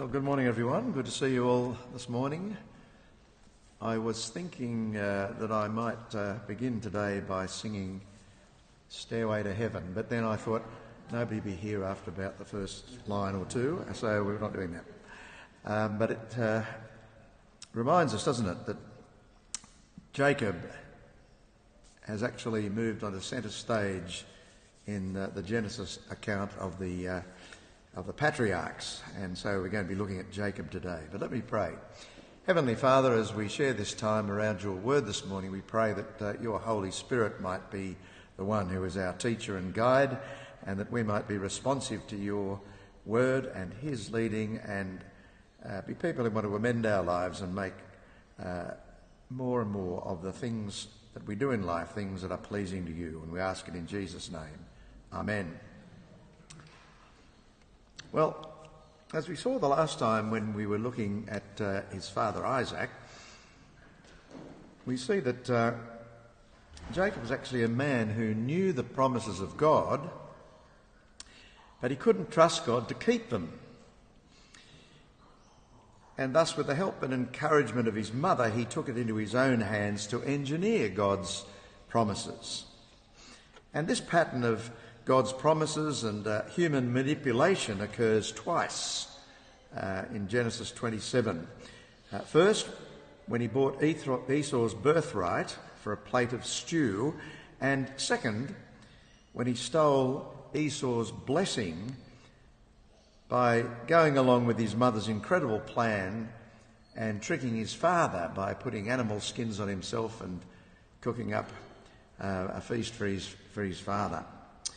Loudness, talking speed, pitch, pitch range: -32 LUFS, 150 wpm, 110 Hz, 100-125 Hz